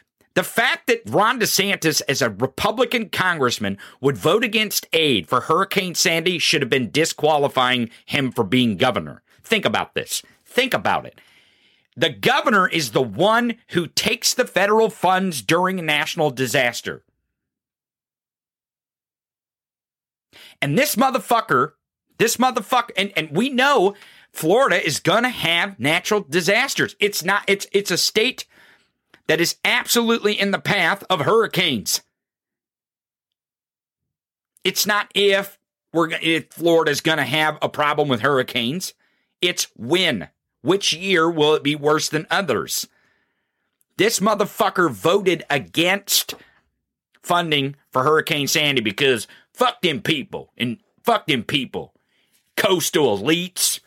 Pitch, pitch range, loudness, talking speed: 175 Hz, 150-205 Hz, -19 LUFS, 125 wpm